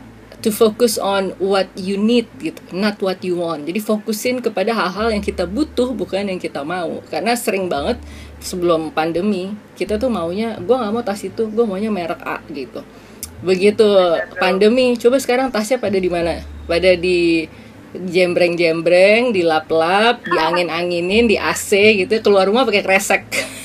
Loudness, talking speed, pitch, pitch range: -17 LUFS, 155 wpm, 195 Hz, 175-225 Hz